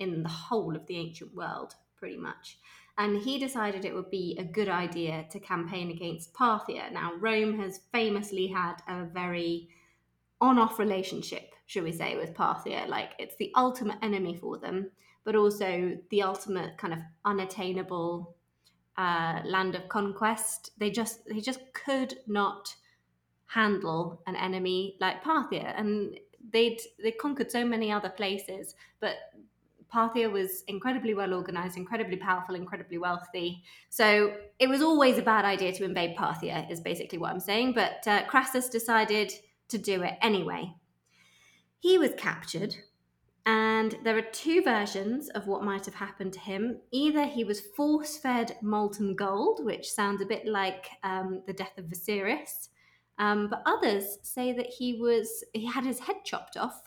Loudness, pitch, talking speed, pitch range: -30 LUFS, 205 Hz, 160 wpm, 185-225 Hz